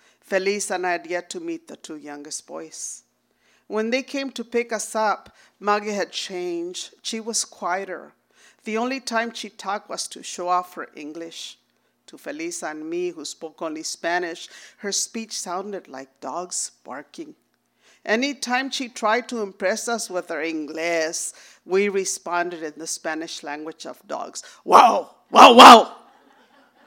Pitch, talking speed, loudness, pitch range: 200 Hz, 155 wpm, -20 LUFS, 170-245 Hz